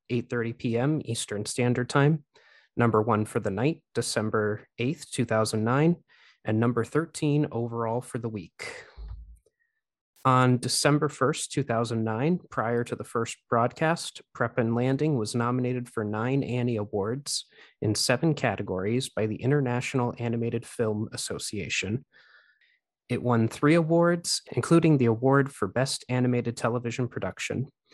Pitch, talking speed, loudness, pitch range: 125 Hz, 125 wpm, -27 LUFS, 115-140 Hz